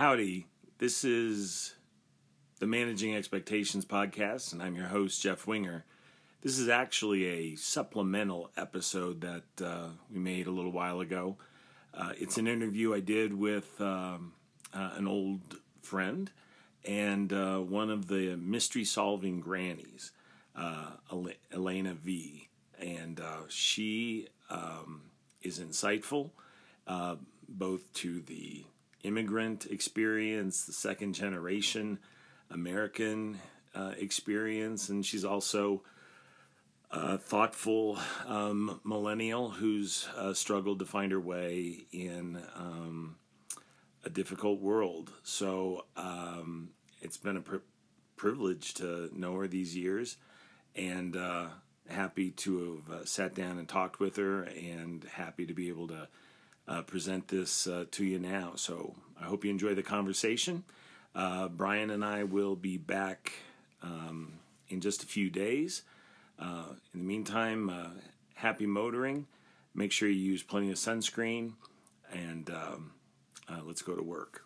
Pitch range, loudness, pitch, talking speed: 90-105 Hz, -35 LUFS, 95 Hz, 135 wpm